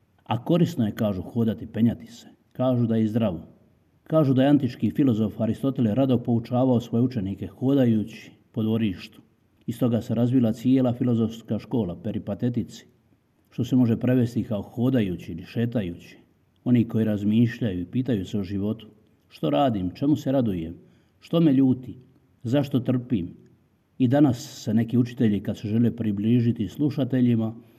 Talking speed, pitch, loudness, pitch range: 145 wpm, 115 Hz, -24 LUFS, 110-130 Hz